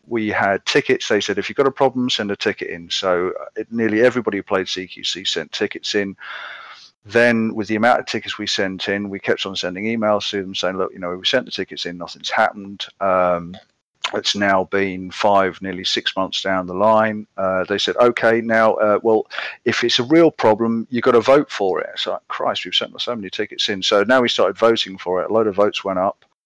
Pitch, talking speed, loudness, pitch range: 105 Hz, 230 wpm, -19 LUFS, 95-115 Hz